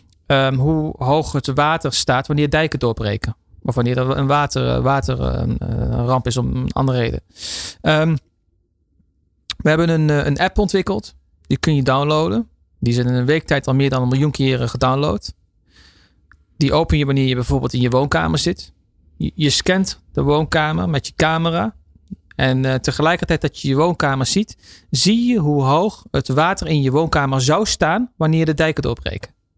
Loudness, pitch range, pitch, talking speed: -18 LUFS, 110-155 Hz, 135 Hz, 170 wpm